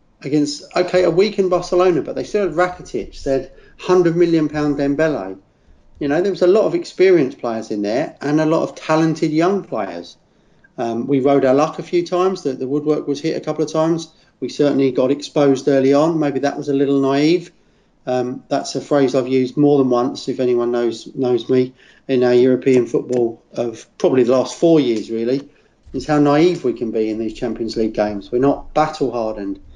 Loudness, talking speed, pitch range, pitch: -18 LUFS, 205 wpm, 125-160 Hz, 140 Hz